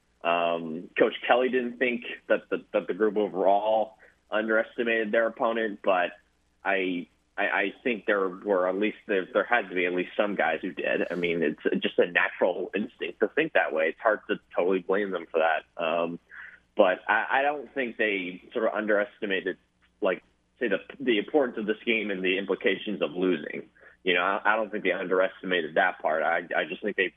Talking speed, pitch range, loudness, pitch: 200 wpm, 85-115 Hz, -27 LUFS, 100 Hz